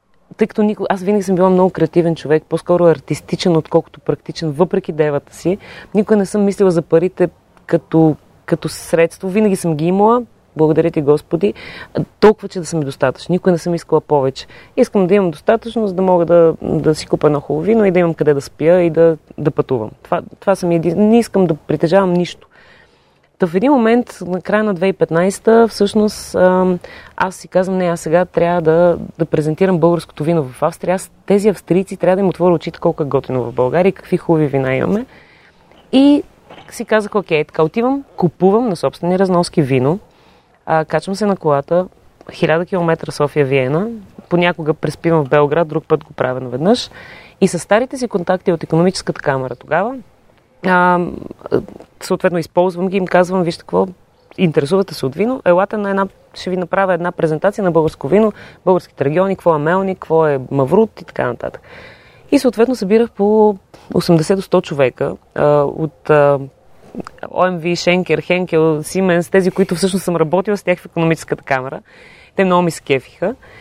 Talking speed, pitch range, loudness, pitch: 175 wpm, 160-195 Hz, -15 LUFS, 175 Hz